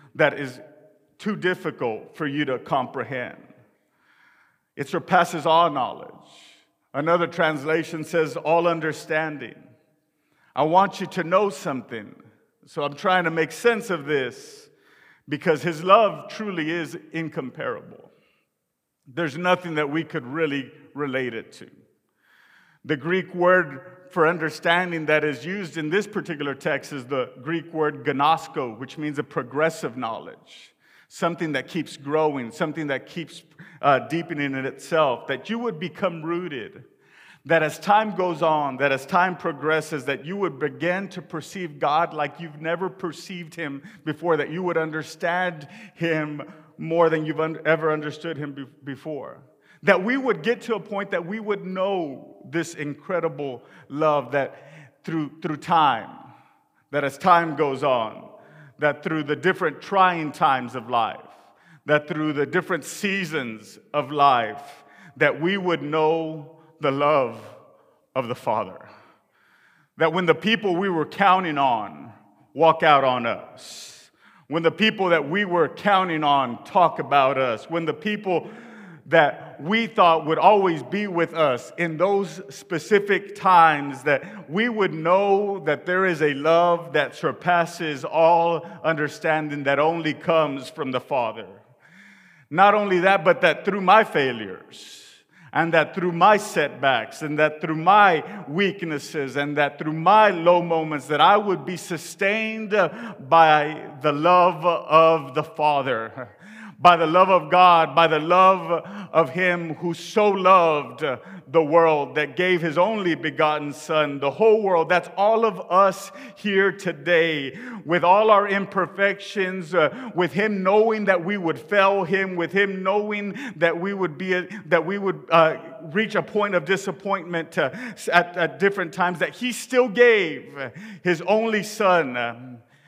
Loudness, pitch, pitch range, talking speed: -22 LUFS, 170 Hz, 155-190 Hz, 150 wpm